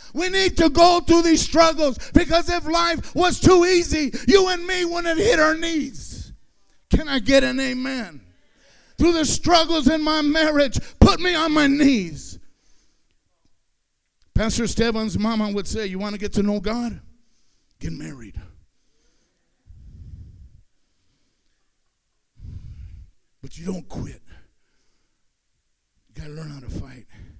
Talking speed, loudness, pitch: 135 wpm, -19 LUFS, 270 Hz